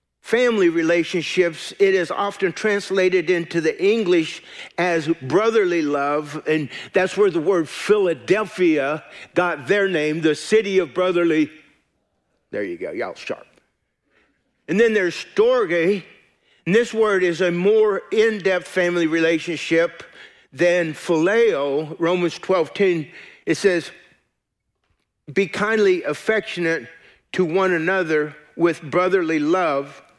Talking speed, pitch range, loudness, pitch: 120 wpm, 165-200 Hz, -20 LUFS, 180 Hz